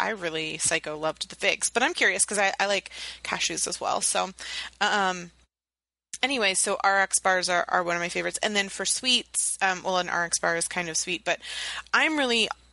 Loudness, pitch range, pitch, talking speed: -25 LUFS, 170-205 Hz, 190 Hz, 205 wpm